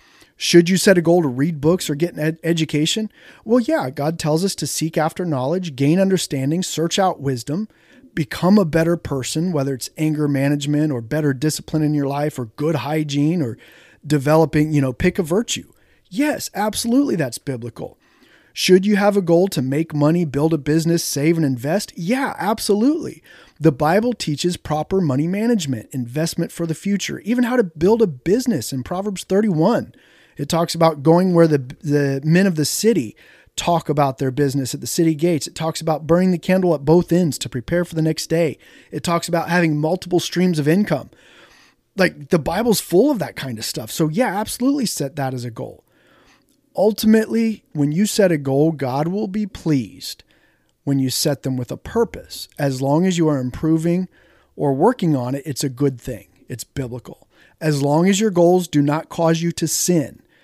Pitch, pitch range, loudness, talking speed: 160 Hz, 145-185 Hz, -19 LUFS, 190 wpm